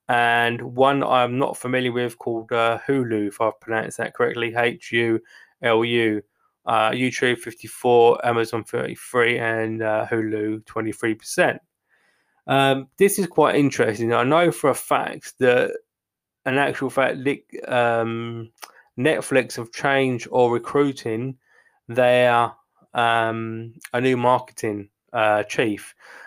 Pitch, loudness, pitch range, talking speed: 120 Hz, -21 LUFS, 115-130 Hz, 120 wpm